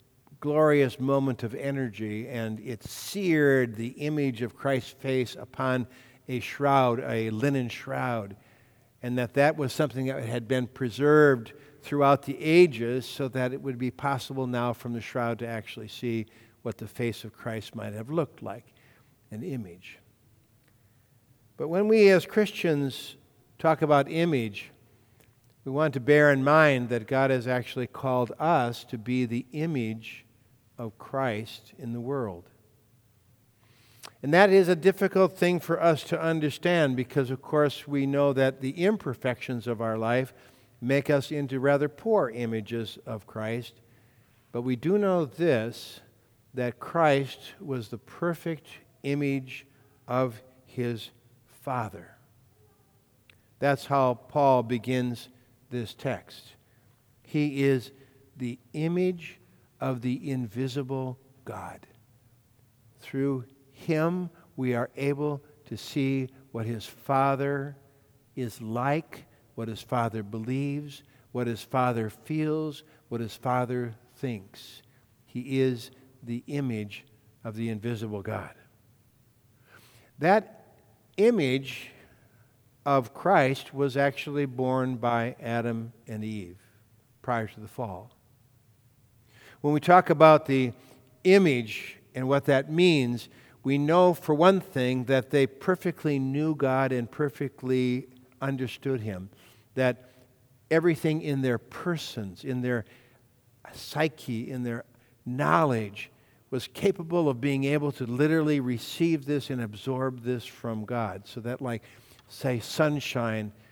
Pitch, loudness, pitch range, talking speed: 125 Hz, -27 LUFS, 115-140 Hz, 125 wpm